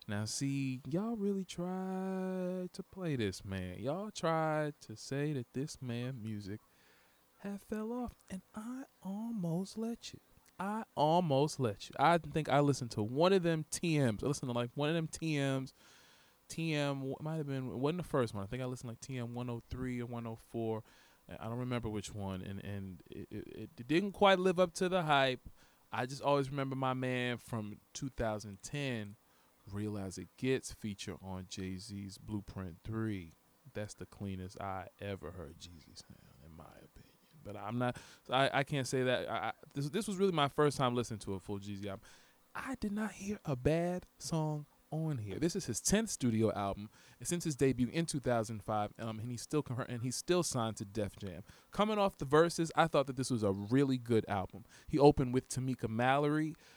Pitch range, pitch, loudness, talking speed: 105-160 Hz, 130 Hz, -36 LUFS, 195 wpm